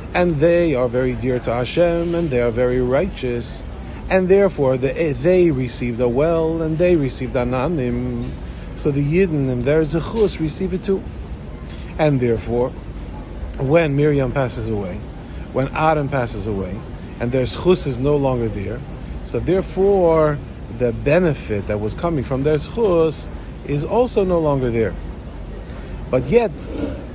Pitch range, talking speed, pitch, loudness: 115-165 Hz, 145 wpm, 130 Hz, -19 LUFS